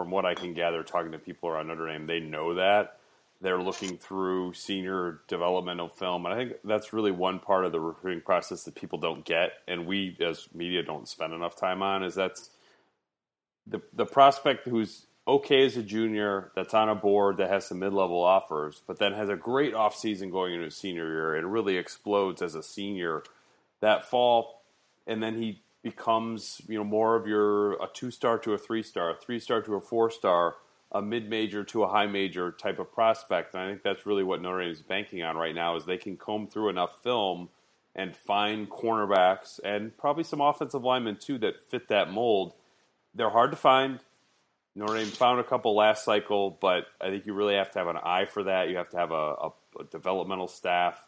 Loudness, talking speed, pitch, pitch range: -29 LUFS, 215 wpm, 100 Hz, 90-110 Hz